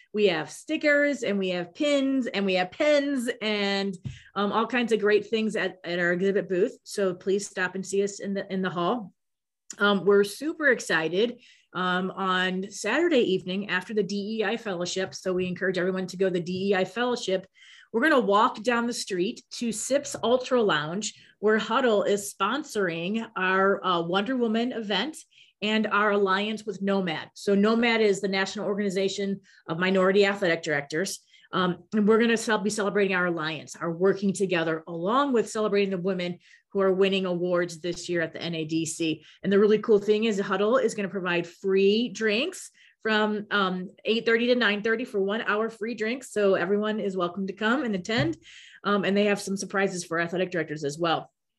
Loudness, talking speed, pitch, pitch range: -26 LUFS, 185 wpm, 200 Hz, 185-220 Hz